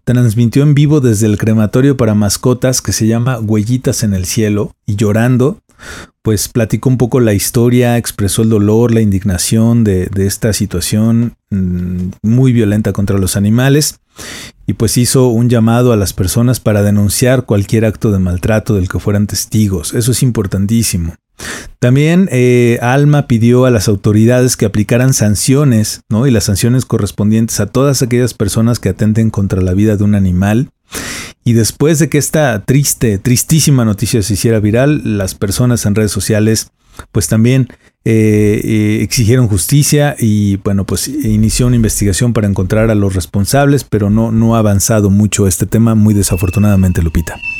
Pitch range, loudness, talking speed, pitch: 105-125 Hz, -11 LUFS, 165 wpm, 110 Hz